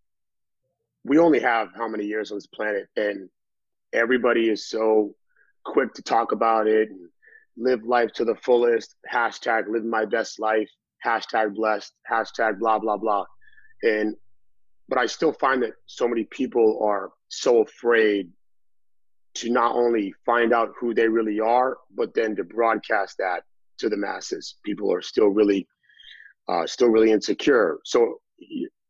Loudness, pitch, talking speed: -23 LUFS, 115 Hz, 150 wpm